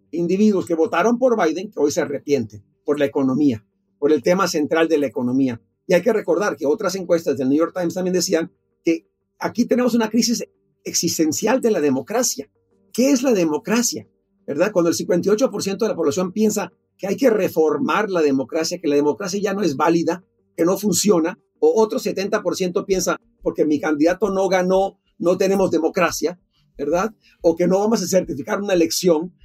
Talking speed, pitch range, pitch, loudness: 185 wpm, 155-200 Hz, 175 Hz, -20 LUFS